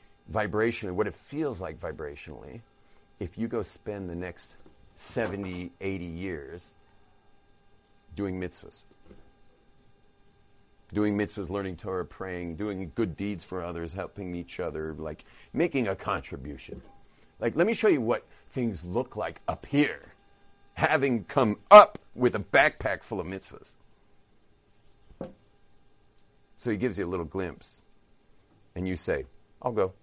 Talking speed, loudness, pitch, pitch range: 130 wpm, -28 LUFS, 100 Hz, 90-105 Hz